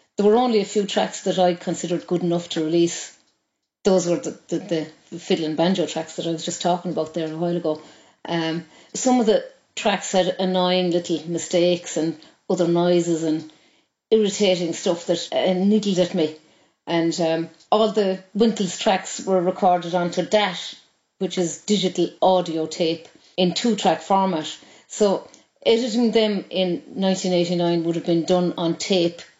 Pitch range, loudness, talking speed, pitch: 165-190 Hz, -22 LUFS, 165 wpm, 175 Hz